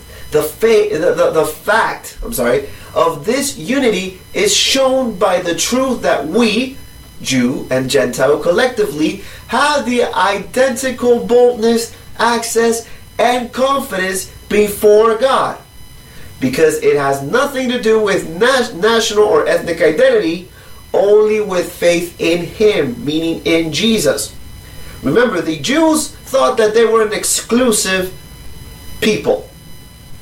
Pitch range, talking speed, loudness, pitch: 180-265 Hz, 120 wpm, -14 LUFS, 225 Hz